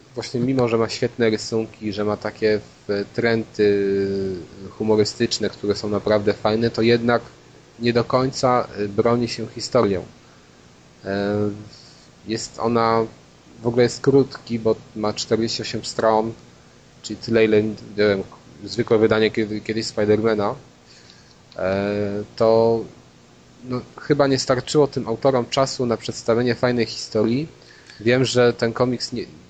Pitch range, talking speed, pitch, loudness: 100-120 Hz, 115 wpm, 110 Hz, -21 LUFS